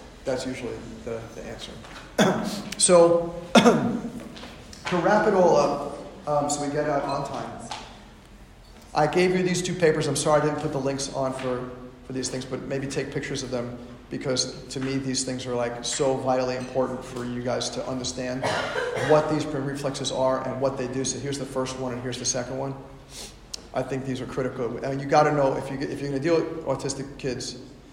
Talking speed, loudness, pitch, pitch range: 215 wpm, -25 LUFS, 135 Hz, 130-150 Hz